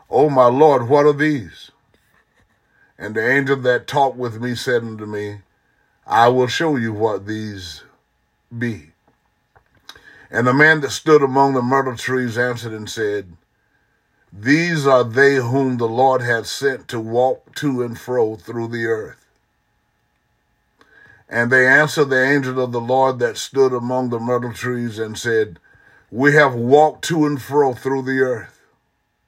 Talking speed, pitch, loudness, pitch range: 155 wpm, 125 Hz, -17 LUFS, 115-135 Hz